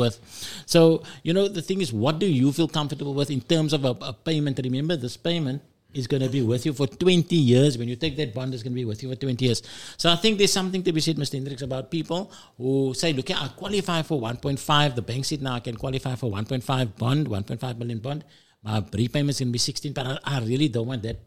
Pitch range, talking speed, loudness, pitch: 125-160 Hz, 255 wpm, -25 LUFS, 135 Hz